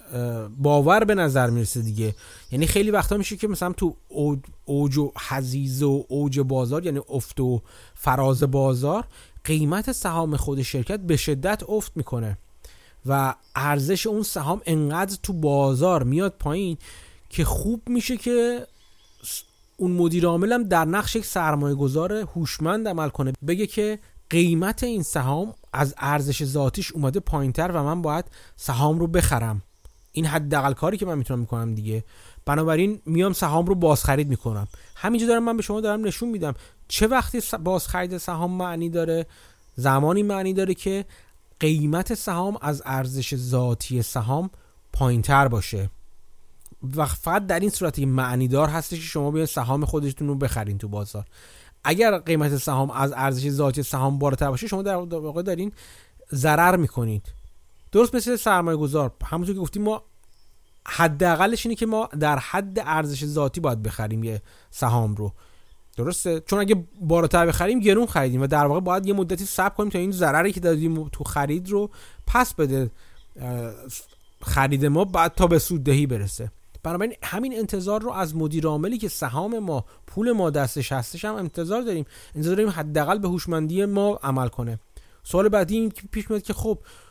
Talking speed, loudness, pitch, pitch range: 155 wpm, -24 LUFS, 155 Hz, 135-190 Hz